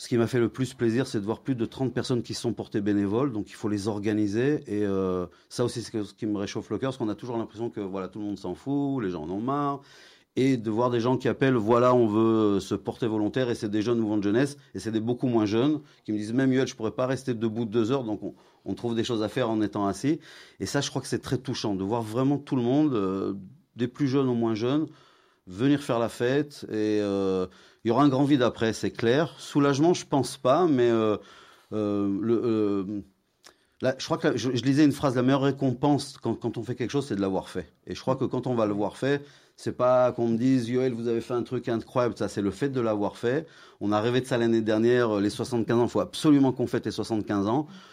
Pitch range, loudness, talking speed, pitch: 105-130 Hz, -27 LUFS, 270 wpm, 115 Hz